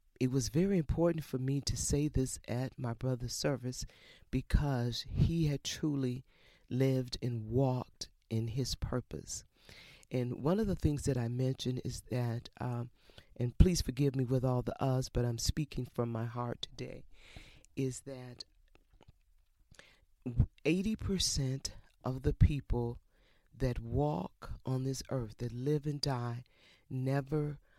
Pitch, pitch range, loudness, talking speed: 125 Hz, 120-135 Hz, -35 LUFS, 140 wpm